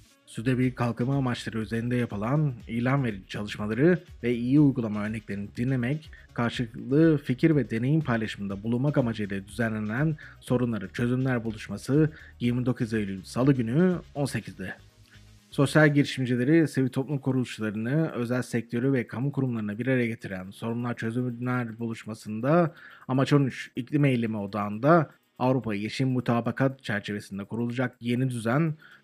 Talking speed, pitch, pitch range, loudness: 120 wpm, 120 Hz, 110-135 Hz, -27 LUFS